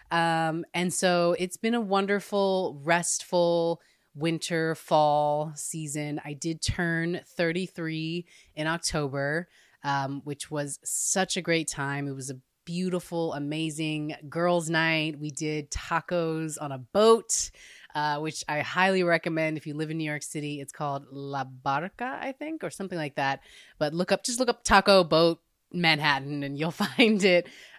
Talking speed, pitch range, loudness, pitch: 155 wpm, 150-180 Hz, -27 LUFS, 160 Hz